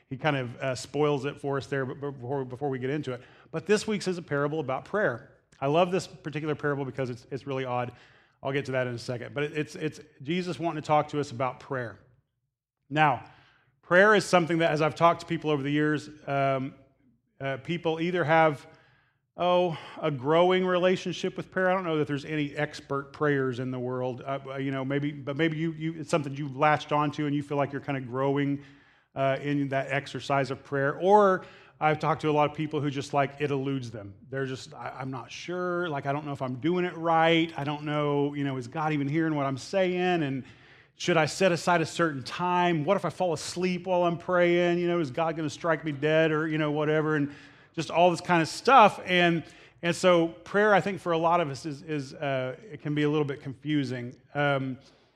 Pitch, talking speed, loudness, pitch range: 150 Hz, 240 wpm, -27 LUFS, 135-165 Hz